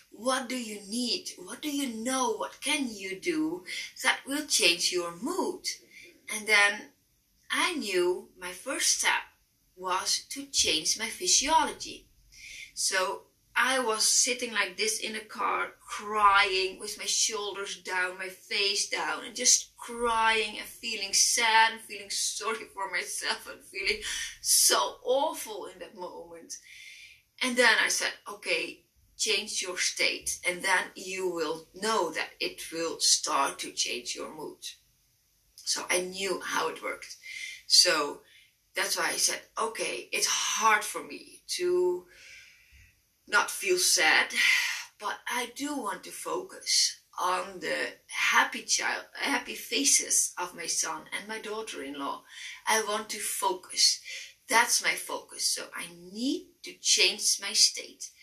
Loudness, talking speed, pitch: -27 LUFS, 140 wpm, 245 Hz